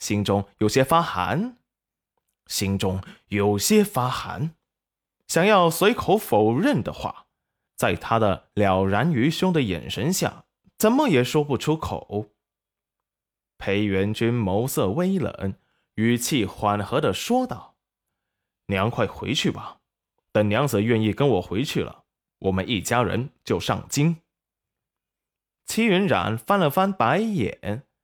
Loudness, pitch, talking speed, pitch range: -23 LUFS, 120 Hz, 180 characters per minute, 100-160 Hz